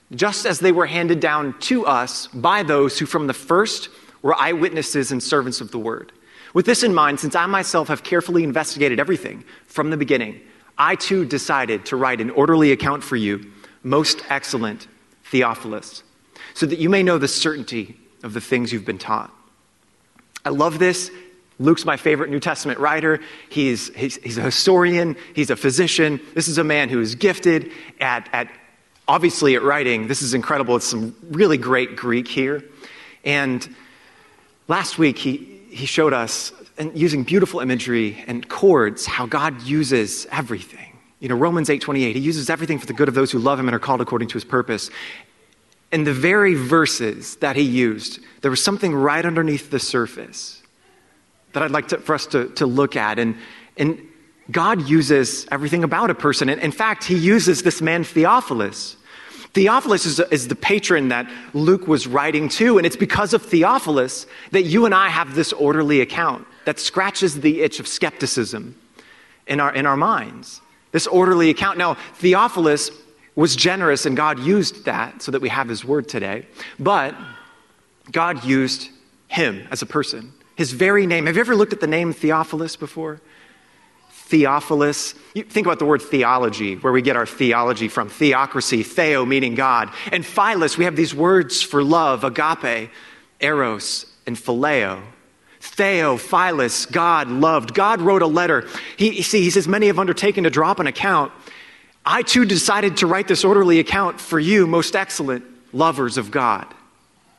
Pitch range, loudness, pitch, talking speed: 130-170 Hz, -19 LUFS, 150 Hz, 175 wpm